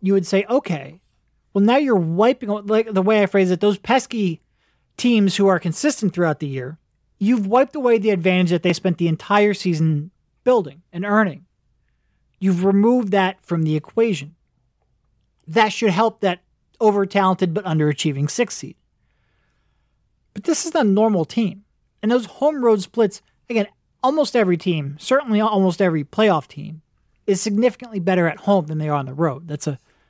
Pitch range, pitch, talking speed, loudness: 170-220 Hz, 195 Hz, 175 wpm, -19 LUFS